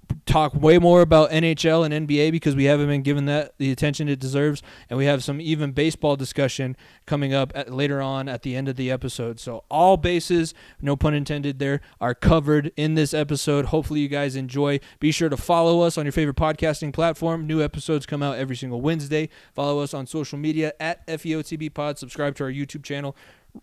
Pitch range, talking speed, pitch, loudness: 140-155 Hz, 205 wpm, 145 Hz, -22 LUFS